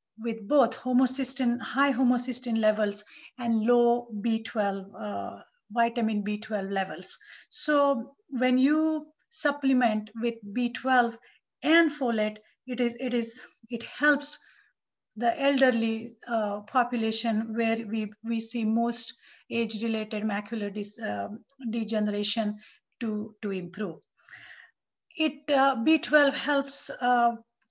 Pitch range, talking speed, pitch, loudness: 215-260 Hz, 110 wpm, 235 Hz, -28 LUFS